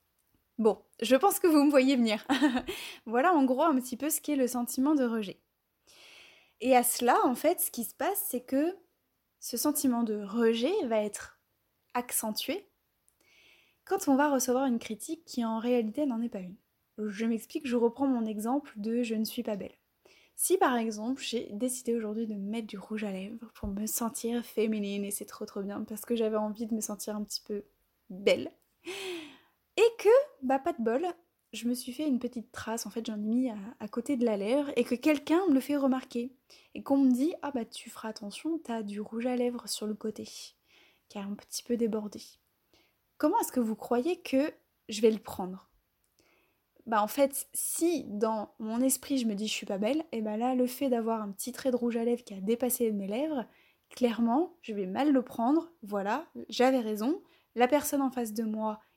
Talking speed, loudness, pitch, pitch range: 210 wpm, -30 LUFS, 240 Hz, 220-275 Hz